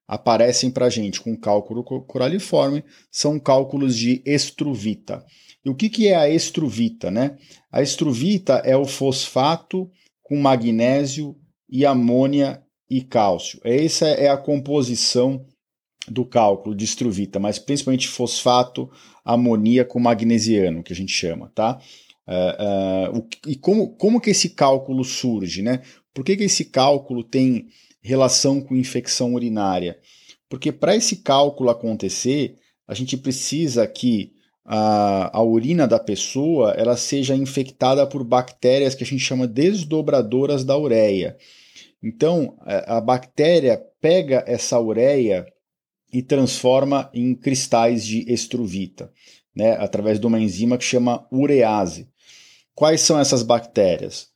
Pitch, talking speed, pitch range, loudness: 130 Hz, 135 wpm, 115-140 Hz, -20 LUFS